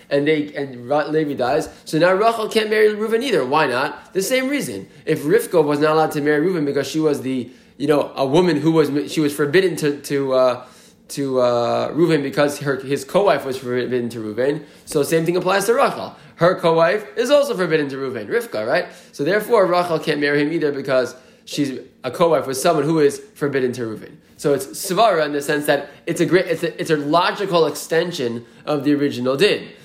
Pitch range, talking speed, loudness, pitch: 140-170 Hz, 215 wpm, -19 LUFS, 150 Hz